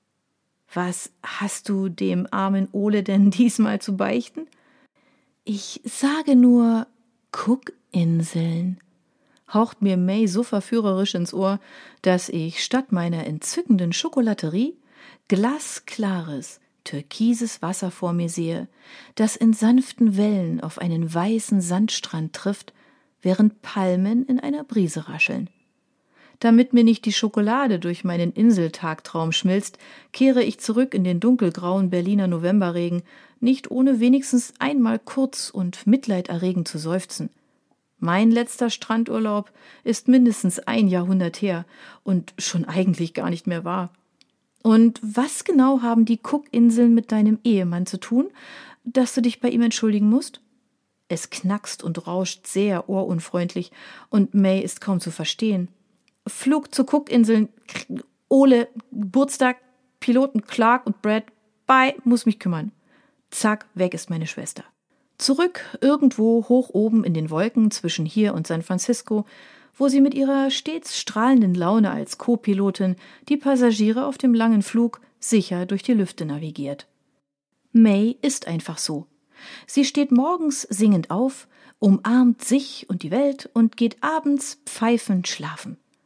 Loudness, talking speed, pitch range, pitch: -21 LUFS, 130 wpm, 185-255 Hz, 220 Hz